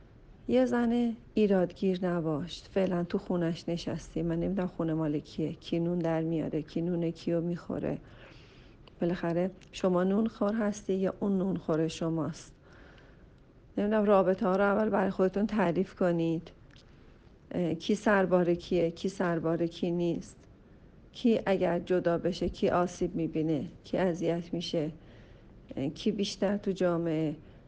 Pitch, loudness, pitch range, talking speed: 175 Hz, -30 LUFS, 165-195 Hz, 130 wpm